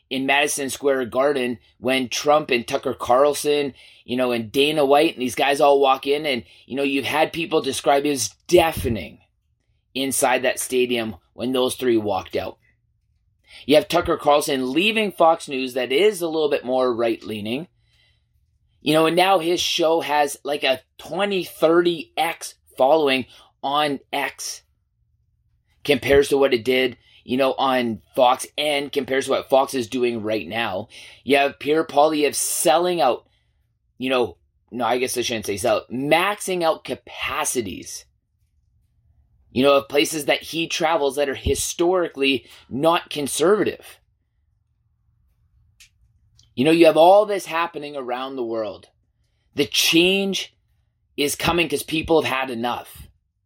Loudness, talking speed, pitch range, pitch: -20 LUFS, 150 wpm, 115-150 Hz, 135 Hz